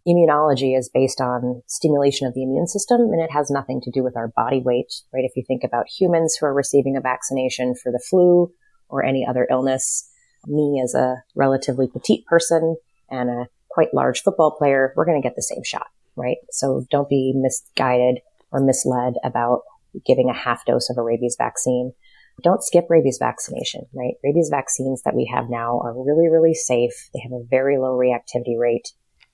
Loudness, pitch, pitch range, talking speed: -20 LUFS, 130 Hz, 125-150 Hz, 190 wpm